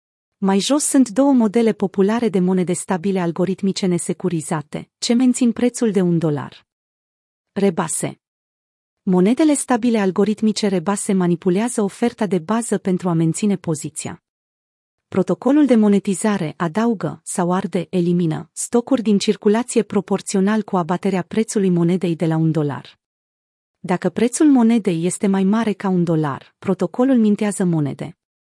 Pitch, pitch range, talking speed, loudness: 195 Hz, 175-220 Hz, 130 wpm, -18 LUFS